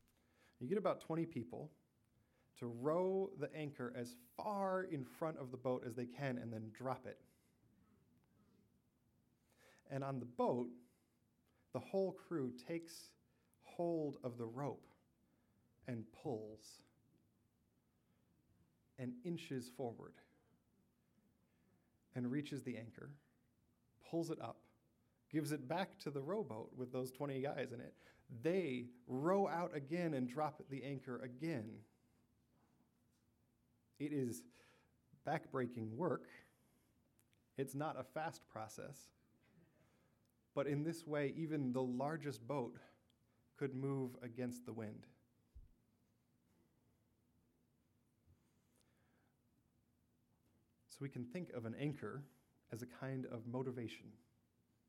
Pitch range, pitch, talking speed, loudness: 120-150 Hz, 130 Hz, 110 wpm, -45 LUFS